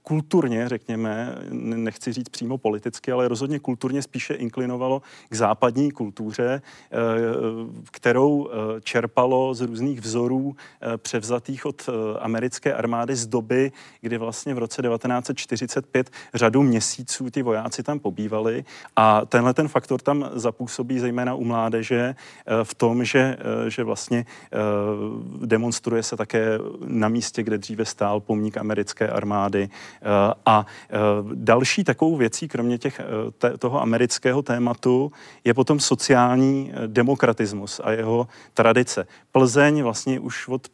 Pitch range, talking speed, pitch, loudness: 115-130 Hz, 120 wpm, 120 Hz, -23 LUFS